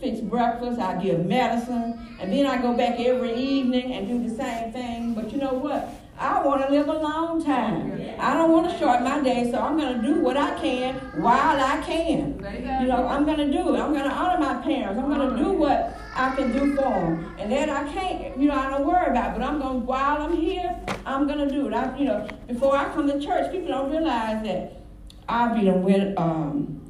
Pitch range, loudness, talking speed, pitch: 235-290 Hz, -24 LUFS, 240 wpm, 265 Hz